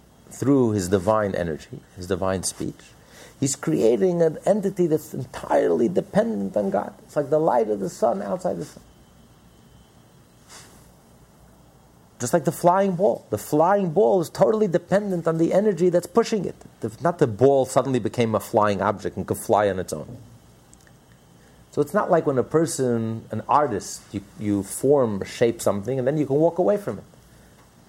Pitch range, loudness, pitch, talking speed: 105-175 Hz, -22 LUFS, 140 Hz, 170 wpm